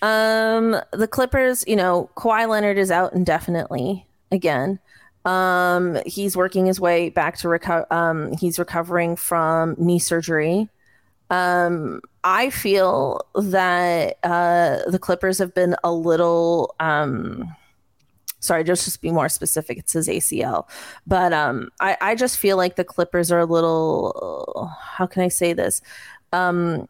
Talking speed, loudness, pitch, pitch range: 145 wpm, -20 LUFS, 180 Hz, 170-195 Hz